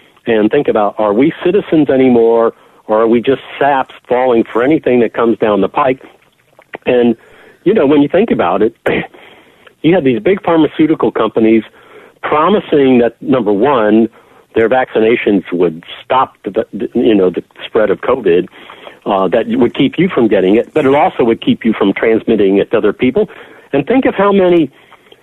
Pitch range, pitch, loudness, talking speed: 115-190 Hz, 135 Hz, -12 LUFS, 175 wpm